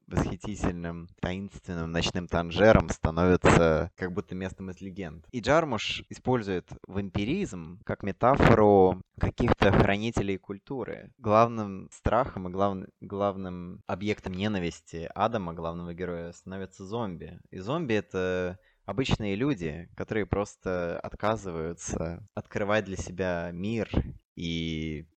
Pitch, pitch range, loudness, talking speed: 95 Hz, 85-105 Hz, -28 LUFS, 105 wpm